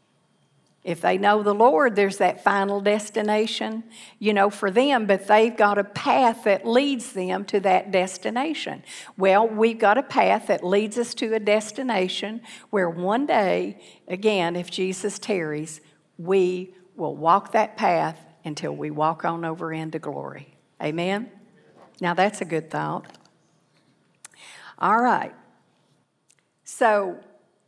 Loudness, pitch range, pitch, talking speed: -23 LUFS, 175-215 Hz, 200 Hz, 135 wpm